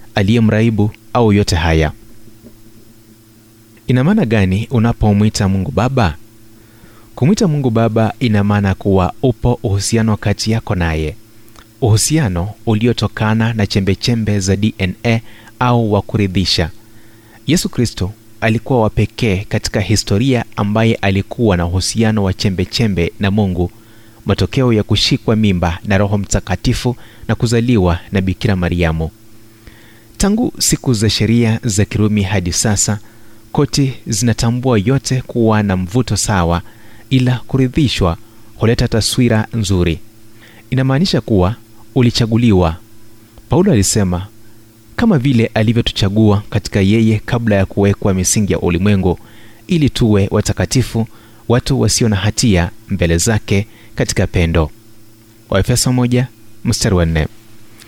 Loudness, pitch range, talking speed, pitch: -15 LUFS, 100-115 Hz, 105 wpm, 110 Hz